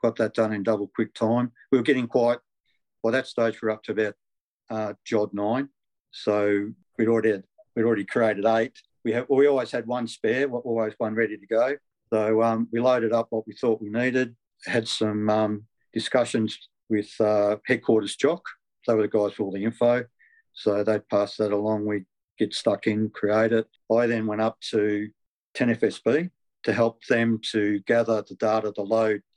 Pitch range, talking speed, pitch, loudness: 105-115 Hz, 195 wpm, 110 Hz, -25 LUFS